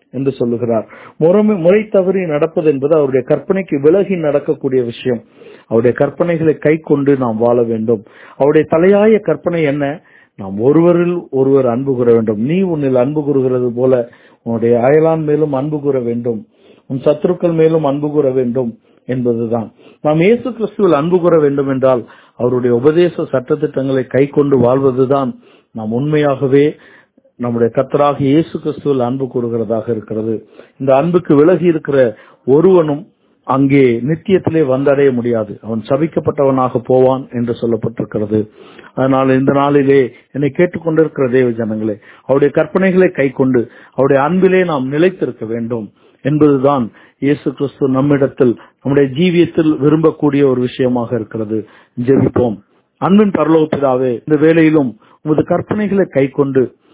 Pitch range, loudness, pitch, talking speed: 125-160 Hz, -14 LUFS, 140 Hz, 120 wpm